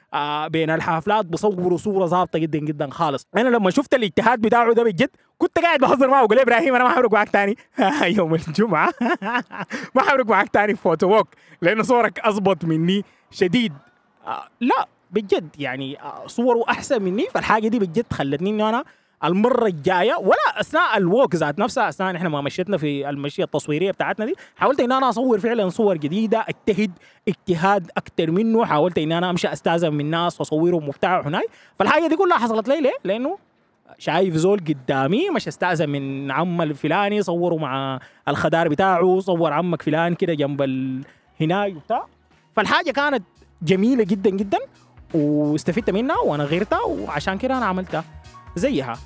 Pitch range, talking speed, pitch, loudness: 160-230 Hz, 155 wpm, 190 Hz, -20 LUFS